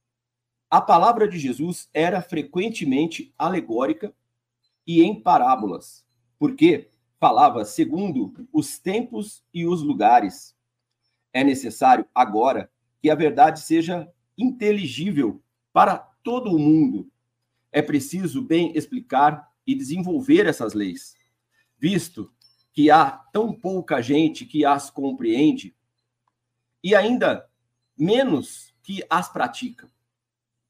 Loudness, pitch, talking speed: -21 LUFS, 155 Hz, 105 wpm